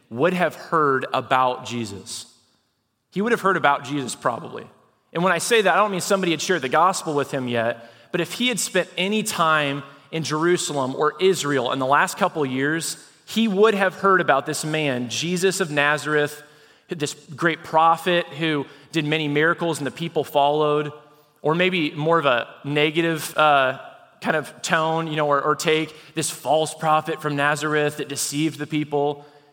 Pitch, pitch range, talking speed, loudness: 155 Hz, 145-170 Hz, 185 wpm, -21 LUFS